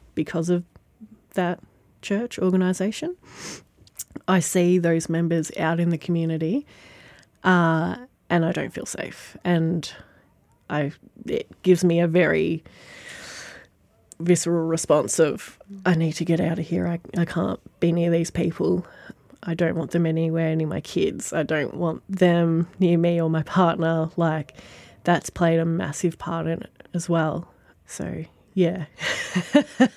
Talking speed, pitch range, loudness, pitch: 145 wpm, 165-180 Hz, -23 LUFS, 170 Hz